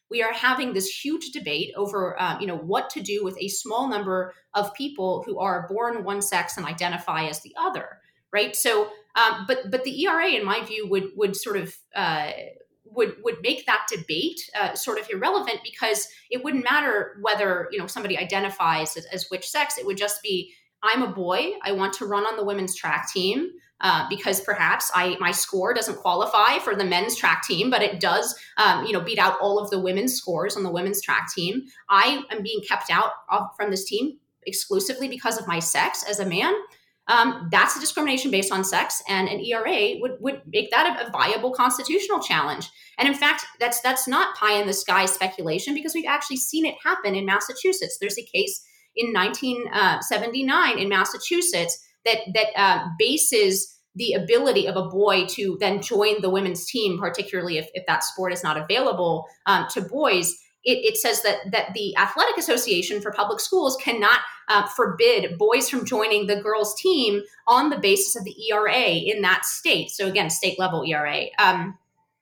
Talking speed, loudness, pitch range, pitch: 195 wpm, -23 LUFS, 190-270 Hz, 210 Hz